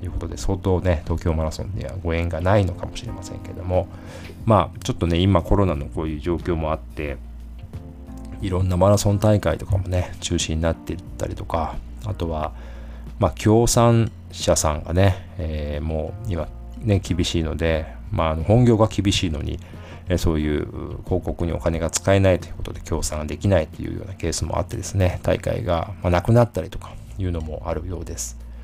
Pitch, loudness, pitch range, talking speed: 90 Hz, -22 LUFS, 80-100 Hz, 340 characters per minute